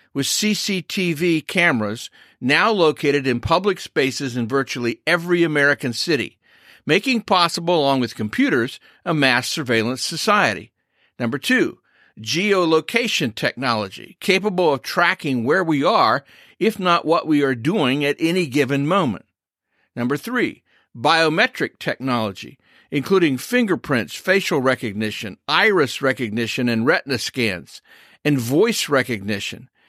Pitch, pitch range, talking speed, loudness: 145 Hz, 125-175 Hz, 115 wpm, -19 LUFS